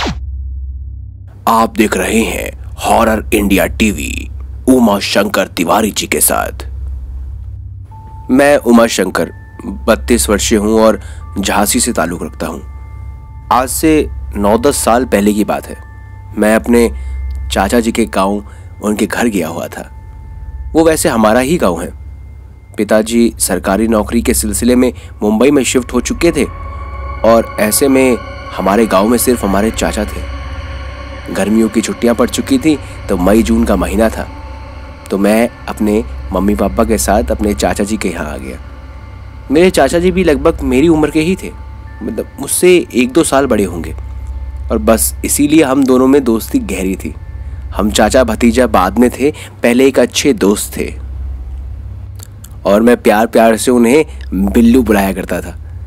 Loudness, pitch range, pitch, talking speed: -12 LUFS, 85-115 Hz, 100 Hz, 155 wpm